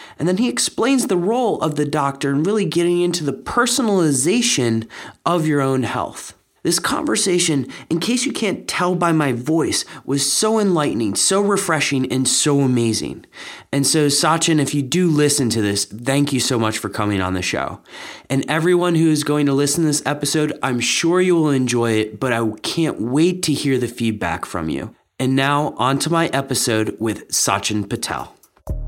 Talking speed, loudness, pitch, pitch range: 185 wpm, -18 LUFS, 145 Hz, 125-165 Hz